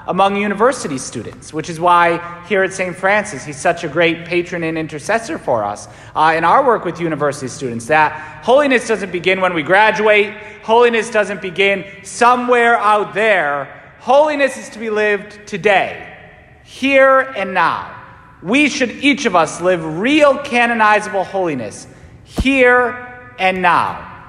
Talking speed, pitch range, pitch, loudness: 150 wpm, 165-230 Hz, 195 Hz, -15 LUFS